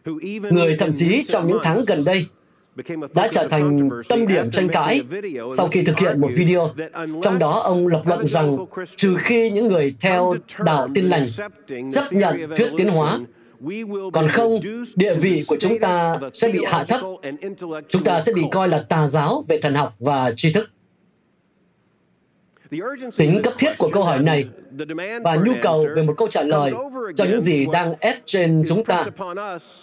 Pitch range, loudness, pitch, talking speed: 155-205 Hz, -19 LUFS, 175 Hz, 175 wpm